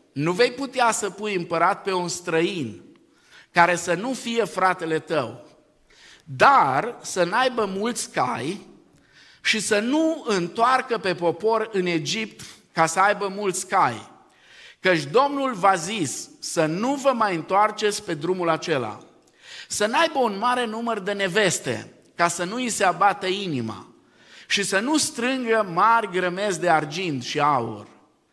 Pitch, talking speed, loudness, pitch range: 200 Hz, 145 wpm, -22 LUFS, 175-235 Hz